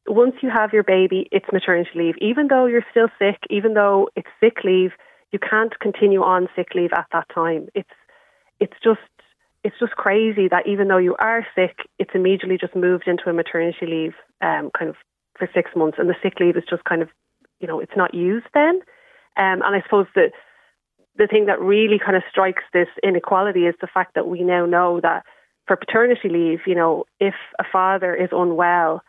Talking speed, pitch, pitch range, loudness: 205 wpm, 190 Hz, 175-215 Hz, -19 LUFS